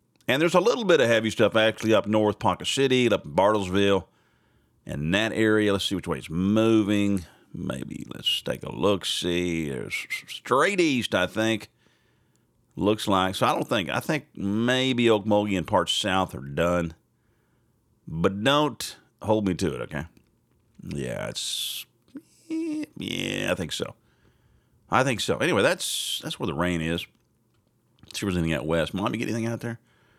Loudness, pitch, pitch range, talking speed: -25 LUFS, 110 Hz, 95-115 Hz, 170 wpm